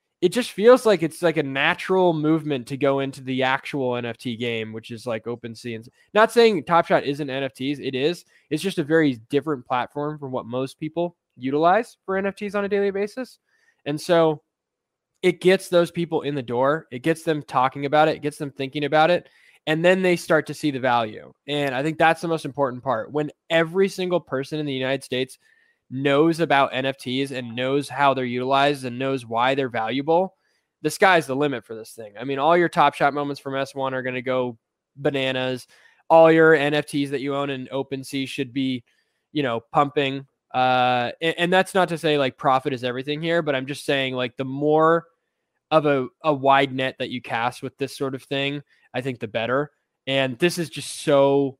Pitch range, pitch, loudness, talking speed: 130-165 Hz, 140 Hz, -22 LUFS, 205 wpm